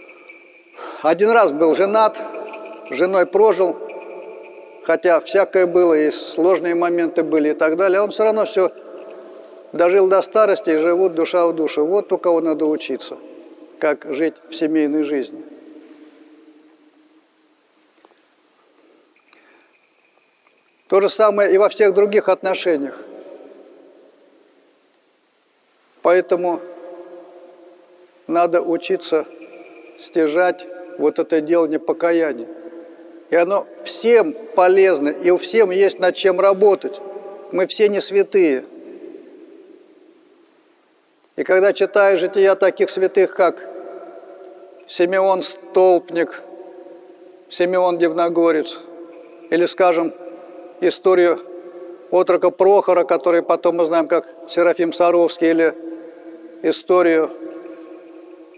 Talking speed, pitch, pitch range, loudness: 100 wpm, 175 Hz, 170-190 Hz, -17 LUFS